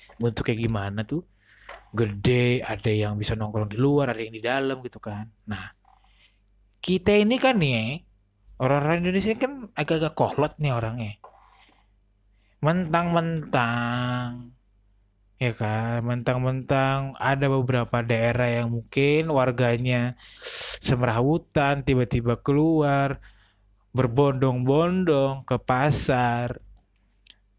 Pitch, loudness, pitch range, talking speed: 125 Hz, -24 LUFS, 110-140 Hz, 100 wpm